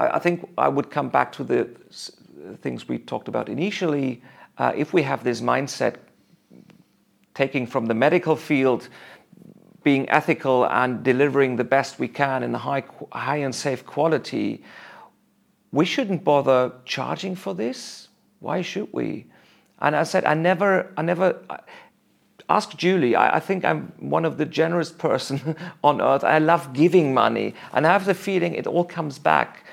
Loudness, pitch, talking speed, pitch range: -22 LUFS, 150 Hz, 165 wpm, 135-175 Hz